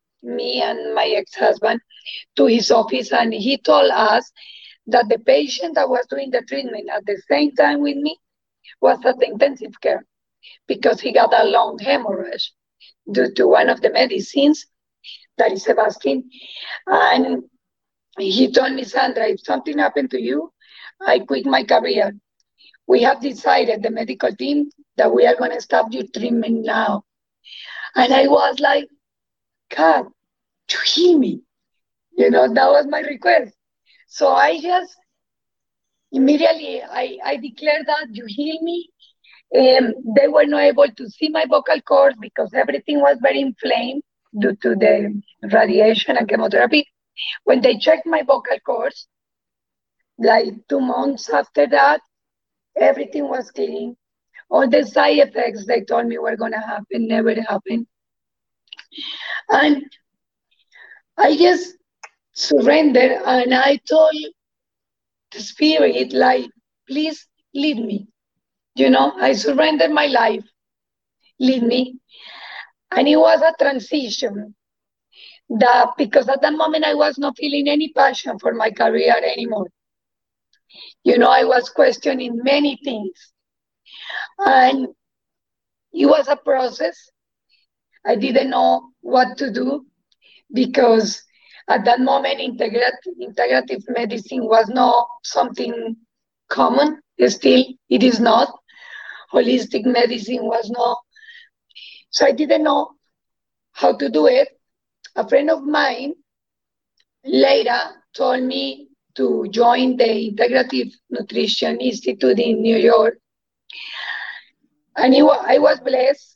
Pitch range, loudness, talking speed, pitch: 230-295 Hz, -17 LUFS, 130 wpm, 265 Hz